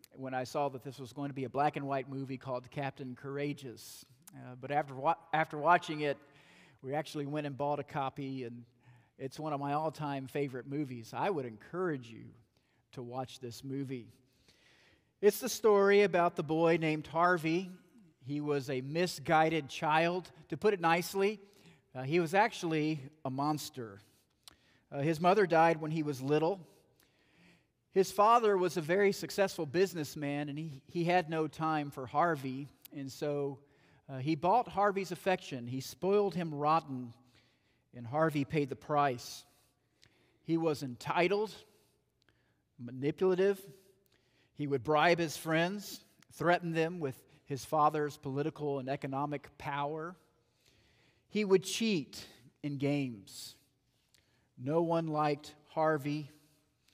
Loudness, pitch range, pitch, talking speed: -33 LUFS, 135-165 Hz, 150 Hz, 145 wpm